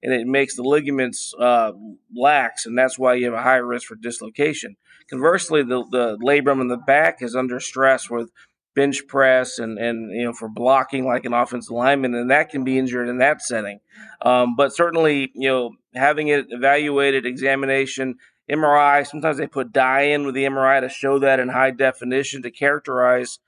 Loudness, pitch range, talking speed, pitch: -19 LUFS, 125-140 Hz, 190 wpm, 130 Hz